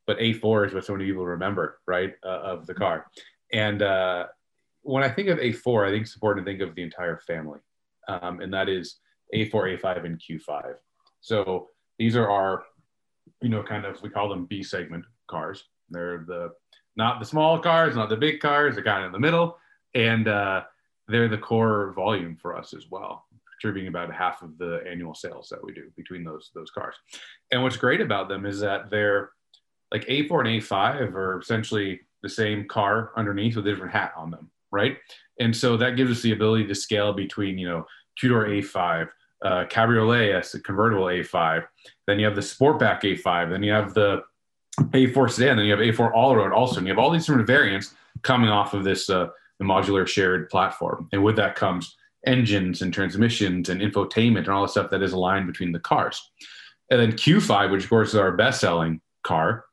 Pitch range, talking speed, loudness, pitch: 95-115 Hz, 205 wpm, -24 LUFS, 105 Hz